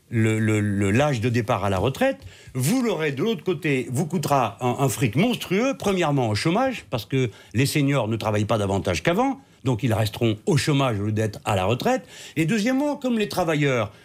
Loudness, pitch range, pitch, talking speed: -23 LUFS, 110-175 Hz, 130 Hz, 205 wpm